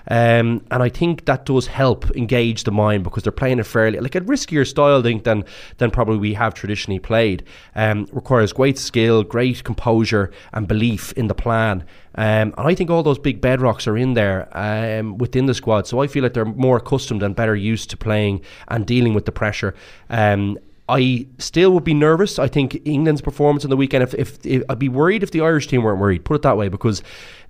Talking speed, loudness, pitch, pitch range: 220 wpm, -18 LUFS, 115 Hz, 105-135 Hz